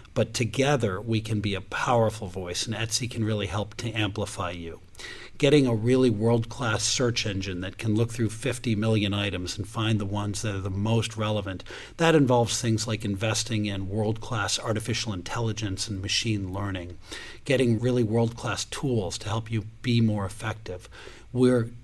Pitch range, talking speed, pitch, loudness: 100-115 Hz, 175 wpm, 110 Hz, -26 LUFS